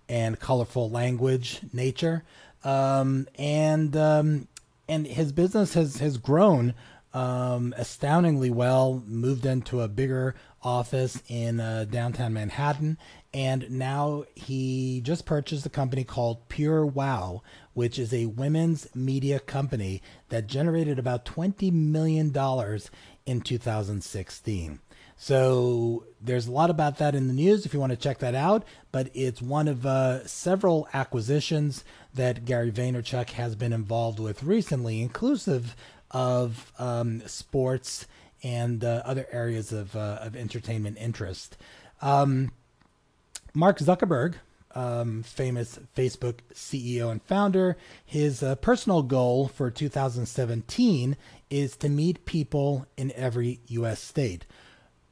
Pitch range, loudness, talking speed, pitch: 120-145 Hz, -27 LUFS, 130 wpm, 130 Hz